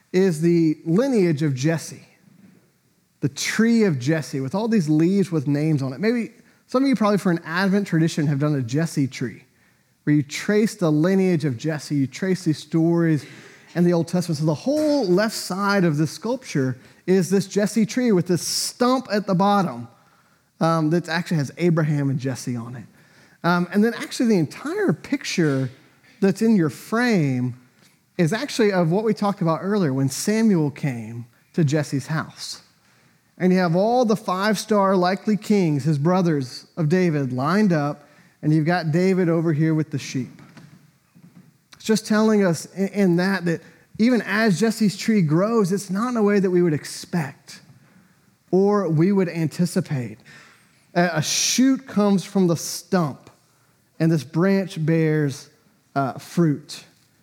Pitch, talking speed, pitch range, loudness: 175 Hz, 165 wpm, 150-200 Hz, -21 LUFS